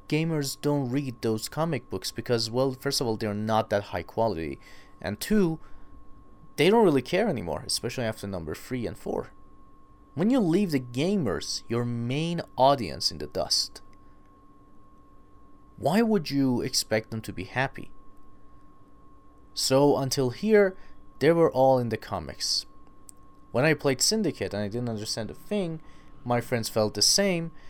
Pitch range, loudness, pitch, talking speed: 105-145 Hz, -26 LUFS, 120 Hz, 155 wpm